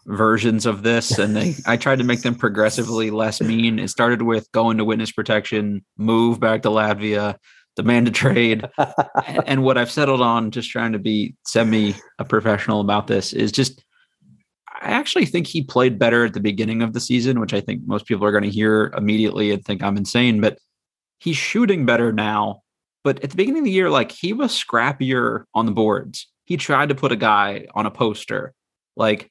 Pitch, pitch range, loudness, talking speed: 115 Hz, 110-130 Hz, -19 LUFS, 205 wpm